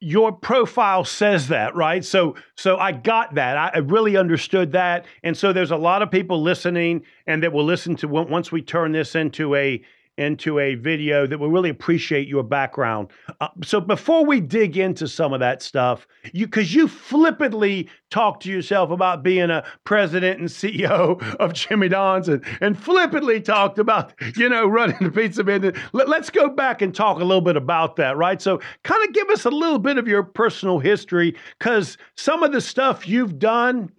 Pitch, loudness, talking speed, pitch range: 185 Hz, -20 LUFS, 195 wpm, 165-220 Hz